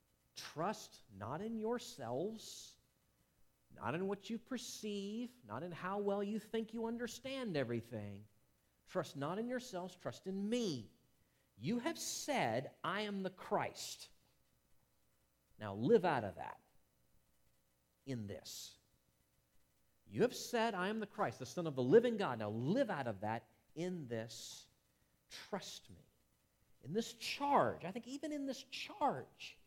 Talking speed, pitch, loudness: 140 wpm, 170 Hz, -41 LUFS